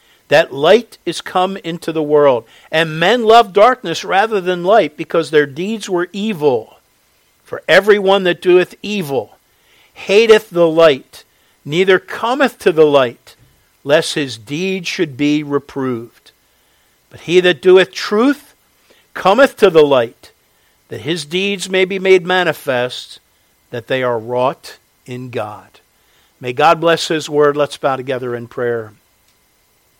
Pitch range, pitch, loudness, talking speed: 145-195 Hz, 170 Hz, -14 LUFS, 140 wpm